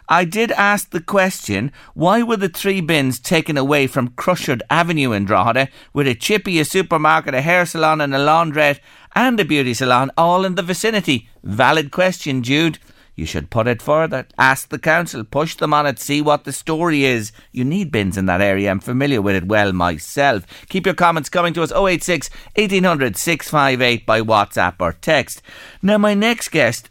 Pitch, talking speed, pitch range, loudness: 150 Hz, 190 wpm, 125-180 Hz, -17 LUFS